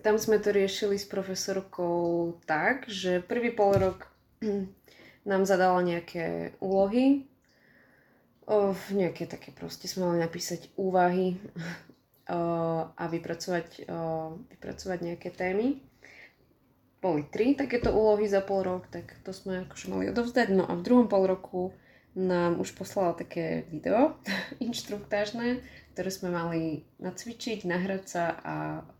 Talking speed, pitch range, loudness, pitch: 125 wpm, 170-205 Hz, -29 LUFS, 185 Hz